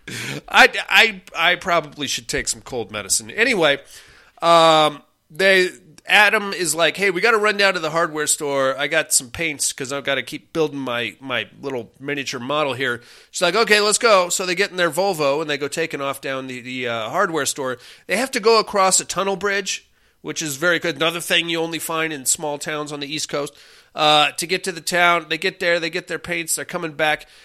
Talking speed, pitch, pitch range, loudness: 225 wpm, 165 Hz, 145-180 Hz, -19 LUFS